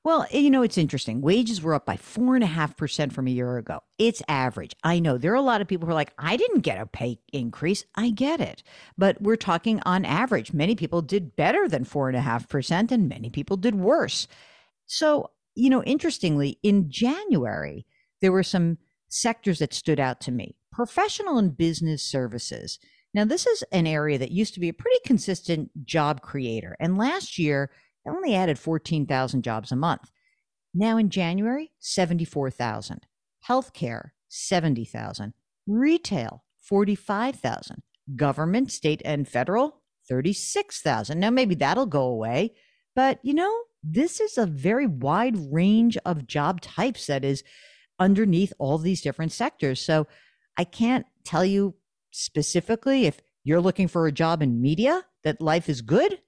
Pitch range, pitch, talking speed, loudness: 145-230 Hz, 175 Hz, 160 wpm, -25 LUFS